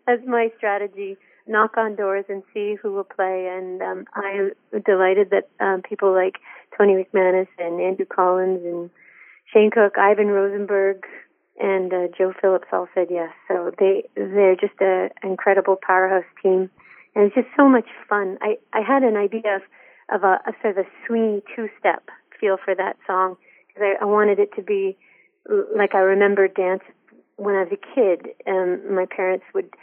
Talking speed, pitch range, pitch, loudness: 175 wpm, 190-220 Hz, 200 Hz, -21 LUFS